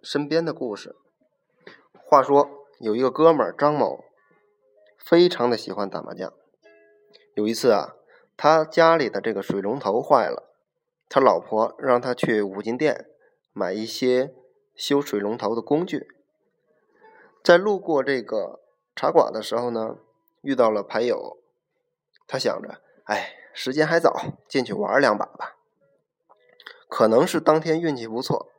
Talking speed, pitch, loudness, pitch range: 200 characters per minute, 145 Hz, -22 LUFS, 115-180 Hz